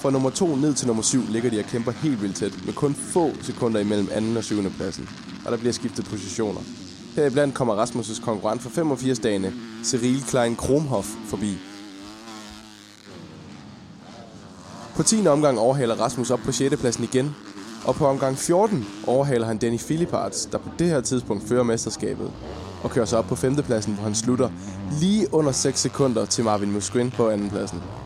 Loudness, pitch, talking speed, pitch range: -23 LUFS, 120 Hz, 180 wpm, 105-130 Hz